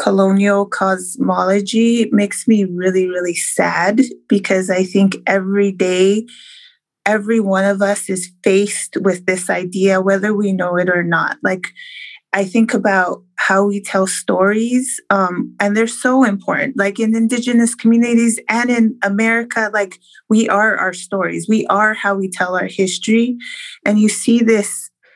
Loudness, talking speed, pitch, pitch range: -15 LUFS, 150 wpm, 205 Hz, 190-230 Hz